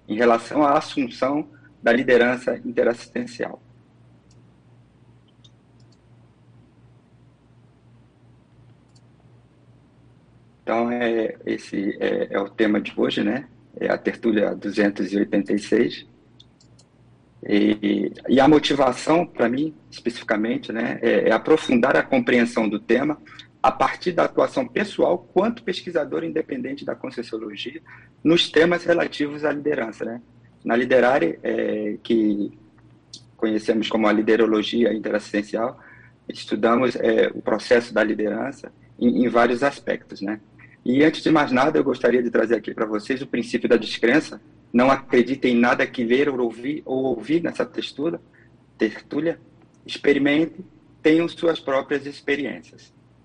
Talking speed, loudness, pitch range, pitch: 120 wpm, -22 LUFS, 105-145 Hz, 120 Hz